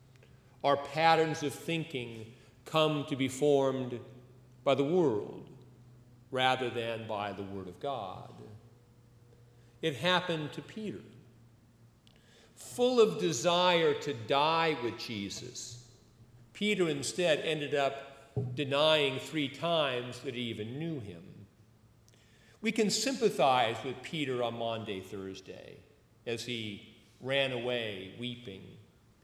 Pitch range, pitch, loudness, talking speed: 115-145 Hz, 125 Hz, -32 LUFS, 110 wpm